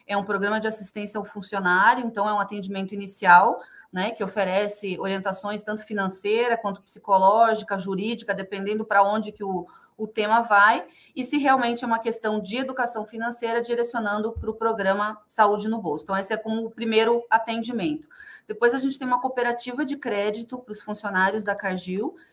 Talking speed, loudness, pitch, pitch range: 175 wpm, -24 LUFS, 215 Hz, 200-235 Hz